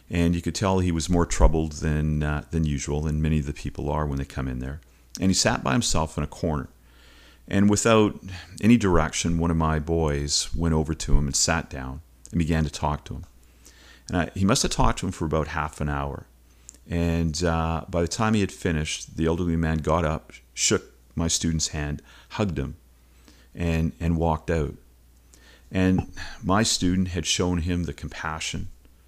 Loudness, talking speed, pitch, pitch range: -25 LUFS, 200 wpm, 80 Hz, 70-85 Hz